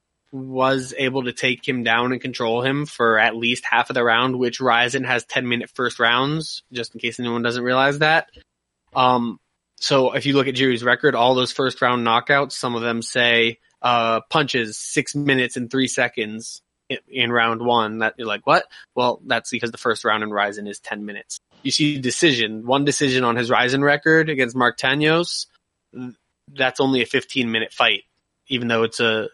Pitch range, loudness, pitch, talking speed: 115-135 Hz, -20 LUFS, 125 Hz, 195 wpm